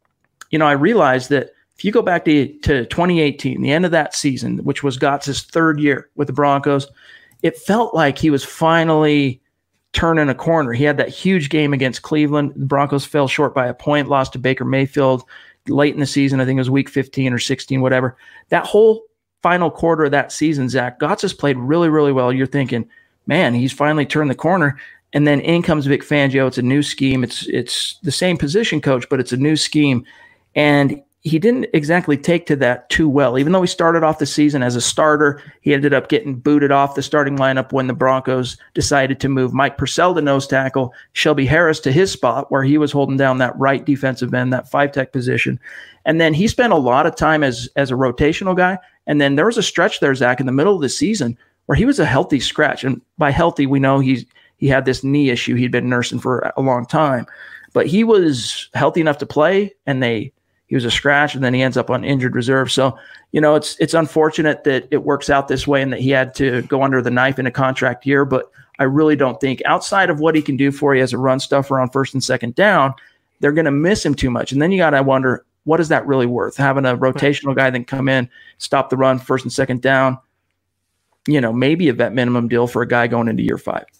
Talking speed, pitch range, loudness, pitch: 235 wpm, 130-150 Hz, -16 LUFS, 140 Hz